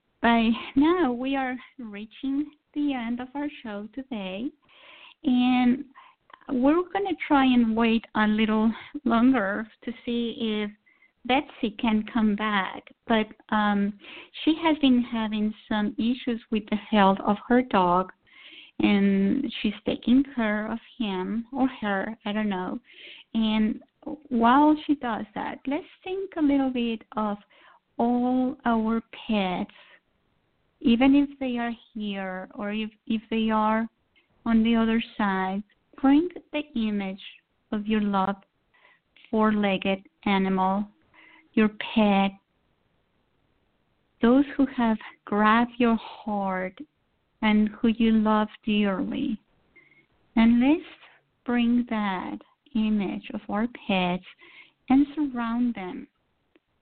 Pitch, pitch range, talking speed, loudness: 230 Hz, 215-270 Hz, 120 wpm, -25 LUFS